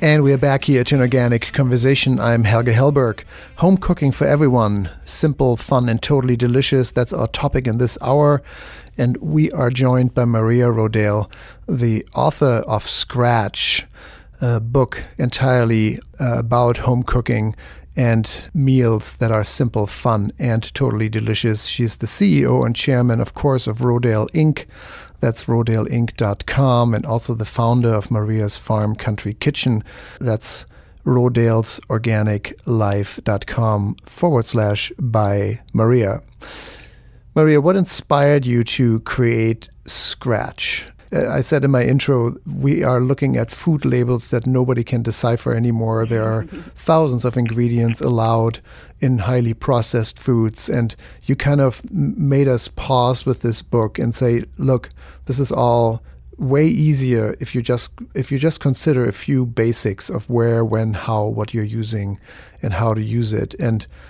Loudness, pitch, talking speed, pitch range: -18 LUFS, 120 Hz, 145 wpm, 110-130 Hz